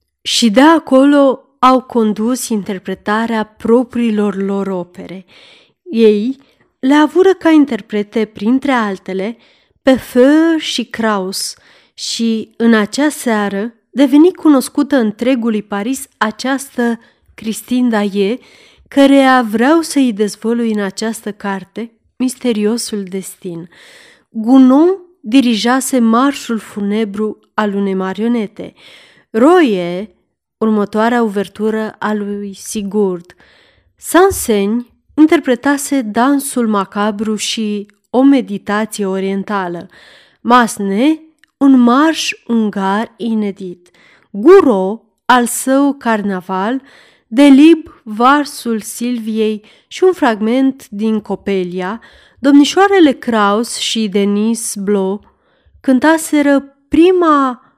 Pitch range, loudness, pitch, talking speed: 205-270 Hz, -13 LUFS, 230 Hz, 90 wpm